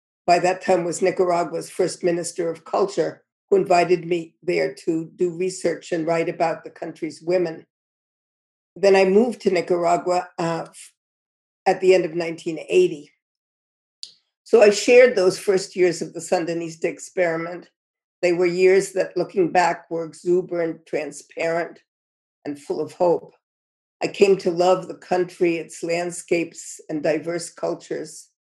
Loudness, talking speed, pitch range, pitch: -21 LUFS, 140 wpm, 165-185 Hz, 175 Hz